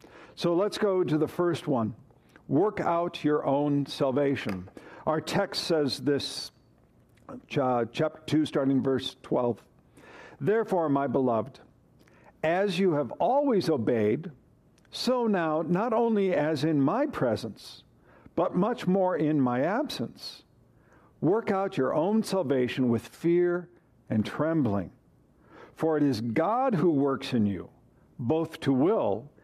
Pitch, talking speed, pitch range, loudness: 150 Hz, 130 wpm, 125-175 Hz, -27 LUFS